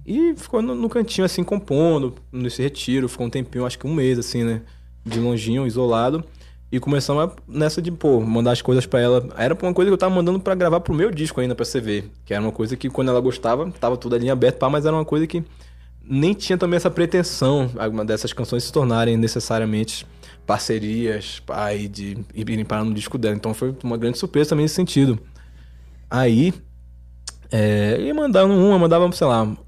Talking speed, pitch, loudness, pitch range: 200 wpm, 125 Hz, -20 LUFS, 110-160 Hz